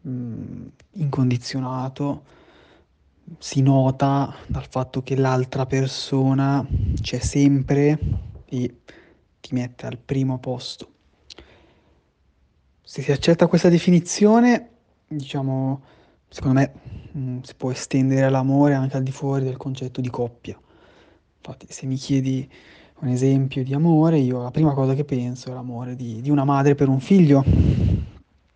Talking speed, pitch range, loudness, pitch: 130 wpm, 125-140 Hz, -21 LUFS, 130 Hz